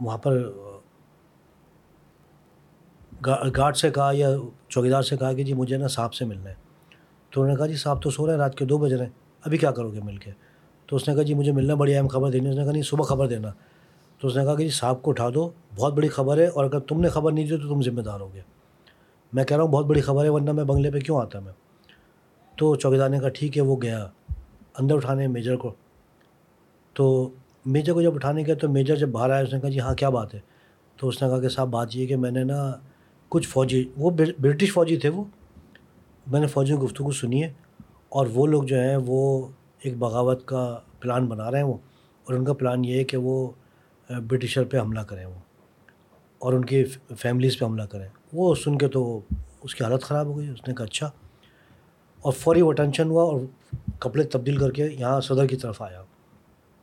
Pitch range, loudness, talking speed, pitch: 125-150 Hz, -24 LUFS, 230 wpm, 135 Hz